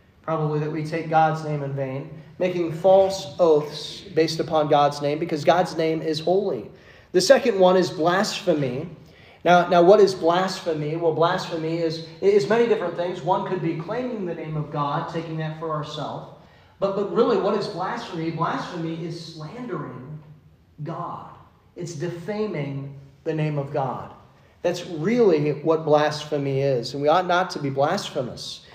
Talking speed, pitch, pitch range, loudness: 160 wpm, 165 Hz, 150-180 Hz, -23 LUFS